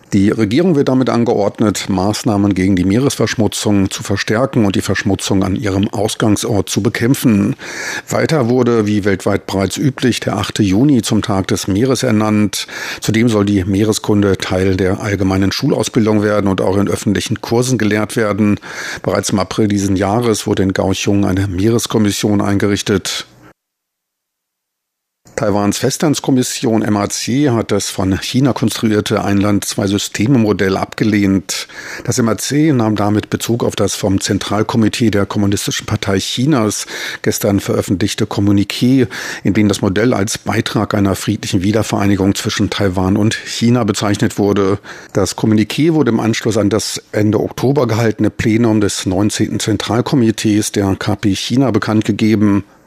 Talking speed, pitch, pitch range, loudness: 135 wpm, 105 Hz, 100-115 Hz, -15 LUFS